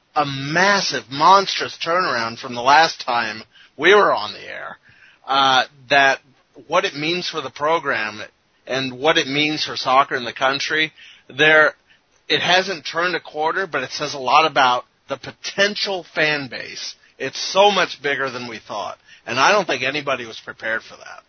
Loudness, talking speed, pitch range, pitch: -18 LUFS, 175 wpm, 130-165 Hz, 150 Hz